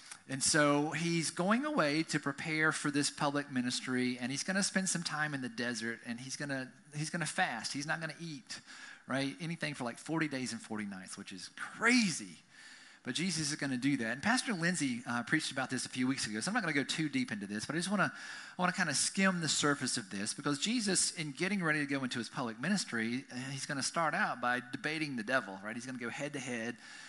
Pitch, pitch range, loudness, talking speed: 145 Hz, 125-160 Hz, -34 LUFS, 255 wpm